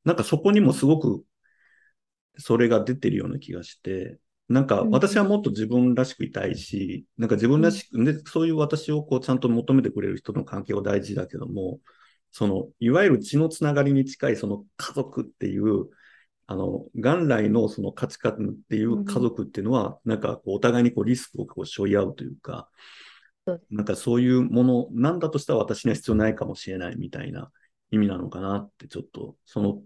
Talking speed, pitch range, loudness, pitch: 390 characters per minute, 110-150 Hz, -24 LUFS, 125 Hz